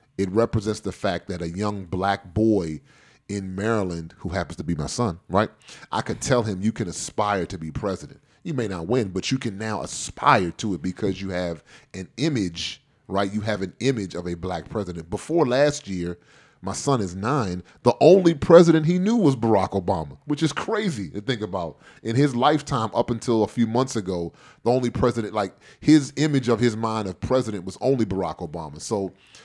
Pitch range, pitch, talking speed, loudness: 95-125 Hz, 105 Hz, 200 wpm, -23 LUFS